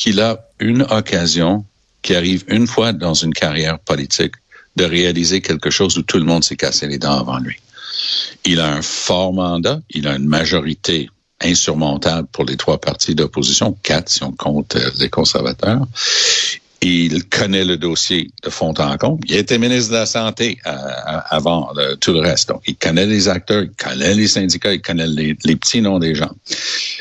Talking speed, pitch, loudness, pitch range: 180 wpm, 85 Hz, -16 LUFS, 75-105 Hz